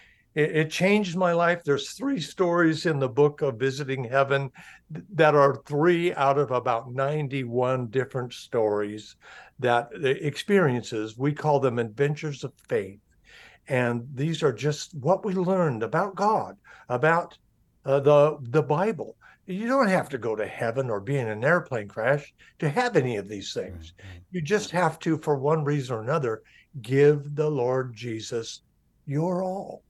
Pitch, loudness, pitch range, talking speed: 145 Hz, -25 LUFS, 125-165 Hz, 160 wpm